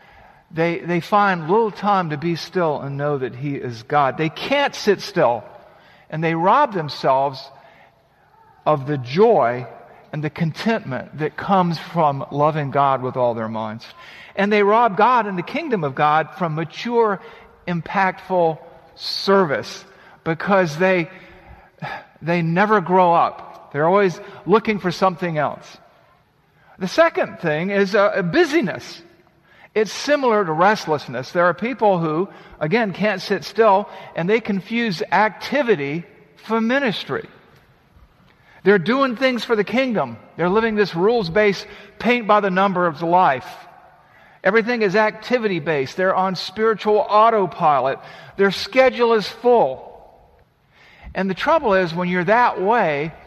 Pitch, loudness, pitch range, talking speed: 190 Hz, -19 LUFS, 165-215 Hz, 135 wpm